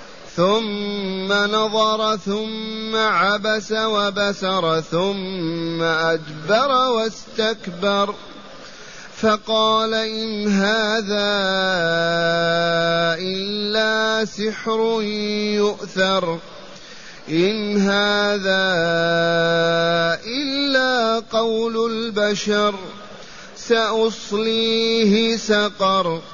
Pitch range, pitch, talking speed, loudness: 185-220 Hz, 205 Hz, 50 wpm, -19 LUFS